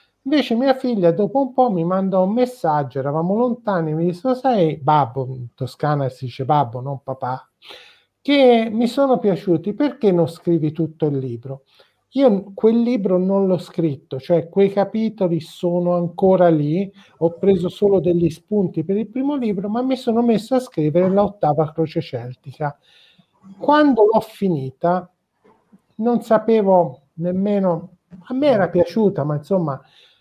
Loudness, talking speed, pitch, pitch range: -19 LUFS, 150 wpm, 180 Hz, 160-220 Hz